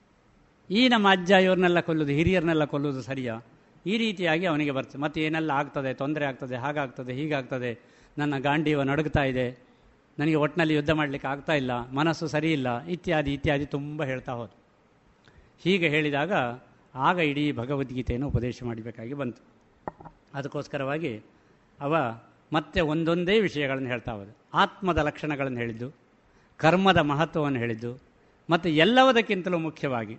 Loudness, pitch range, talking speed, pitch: -26 LUFS, 130-160 Hz, 120 wpm, 145 Hz